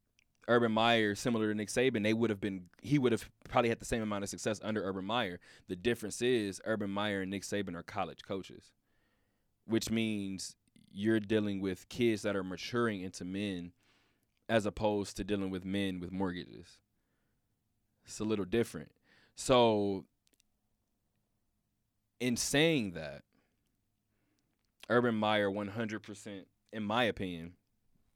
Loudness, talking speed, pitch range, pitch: -34 LUFS, 145 wpm, 100-115 Hz, 105 Hz